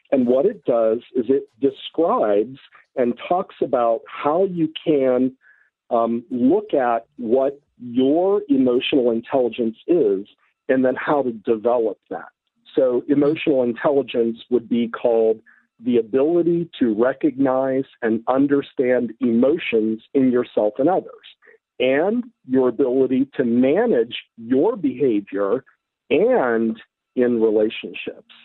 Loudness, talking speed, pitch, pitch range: -20 LUFS, 115 wpm, 130 Hz, 120-150 Hz